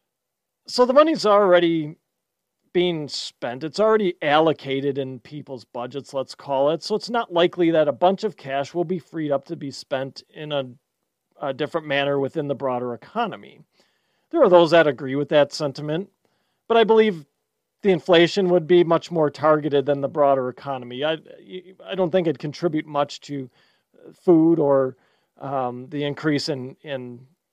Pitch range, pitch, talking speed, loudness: 140-175 Hz, 150 Hz, 170 wpm, -21 LUFS